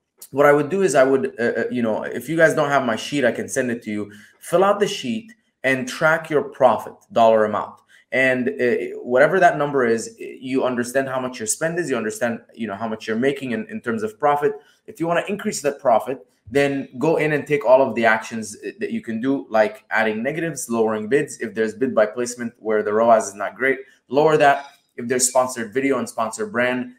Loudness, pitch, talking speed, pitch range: -20 LUFS, 135 Hz, 230 wpm, 115-155 Hz